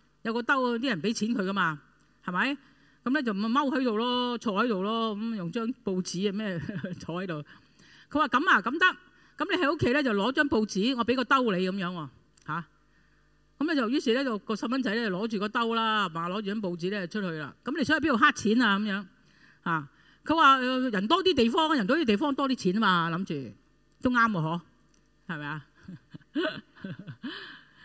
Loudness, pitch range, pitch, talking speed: -27 LUFS, 180-260 Hz, 220 Hz, 280 characters per minute